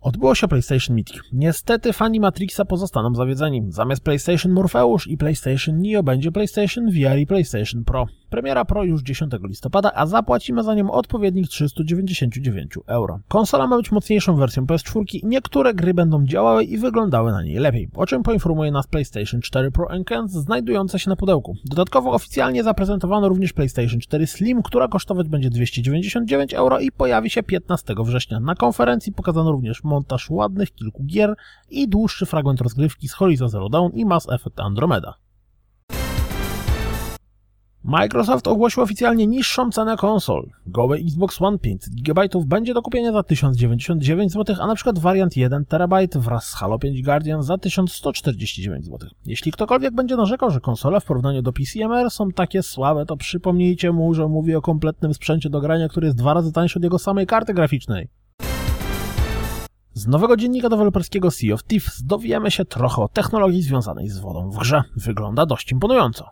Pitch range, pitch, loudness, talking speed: 125-195 Hz, 155 Hz, -20 LUFS, 165 wpm